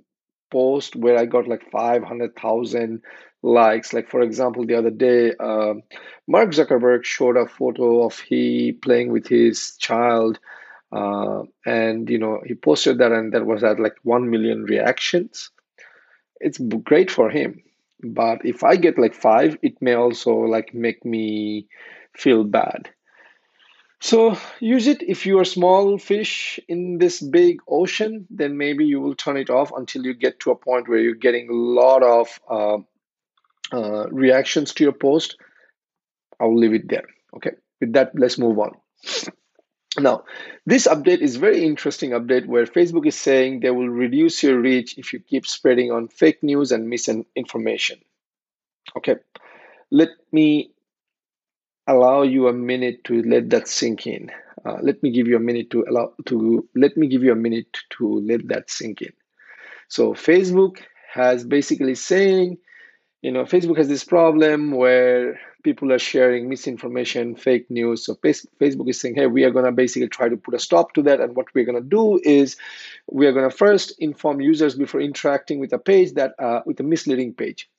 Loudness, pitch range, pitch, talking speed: -19 LUFS, 120-160 Hz, 130 Hz, 170 wpm